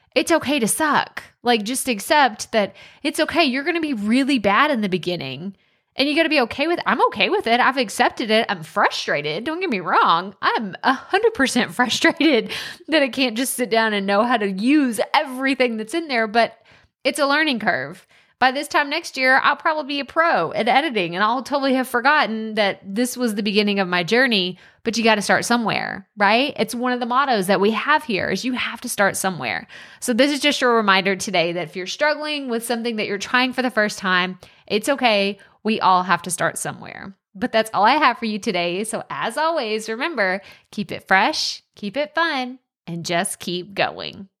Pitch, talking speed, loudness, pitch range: 240 Hz, 215 wpm, -20 LUFS, 200-275 Hz